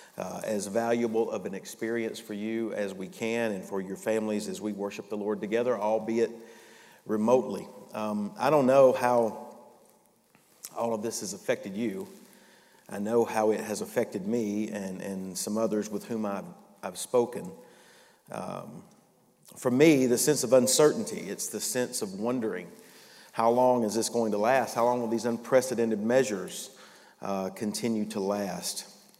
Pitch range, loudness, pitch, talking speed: 105-120 Hz, -28 LUFS, 115 Hz, 160 wpm